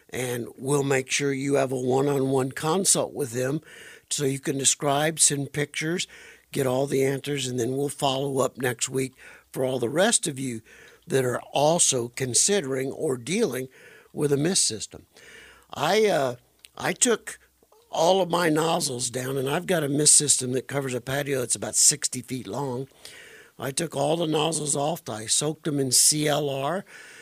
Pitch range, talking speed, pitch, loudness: 130-155 Hz, 175 wpm, 140 Hz, -24 LUFS